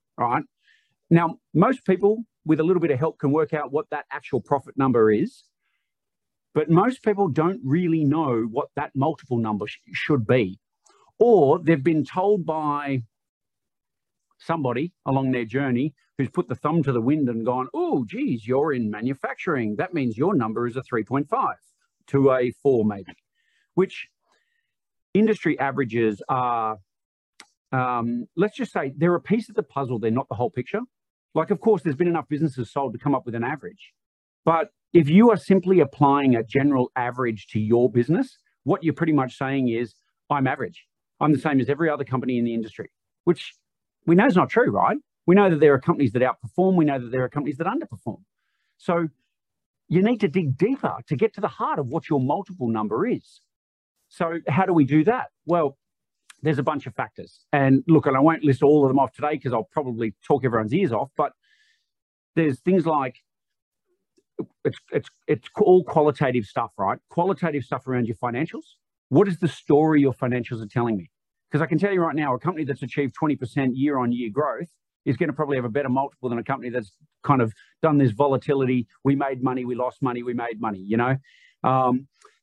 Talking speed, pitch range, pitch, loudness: 195 wpm, 125-170 Hz, 145 Hz, -23 LUFS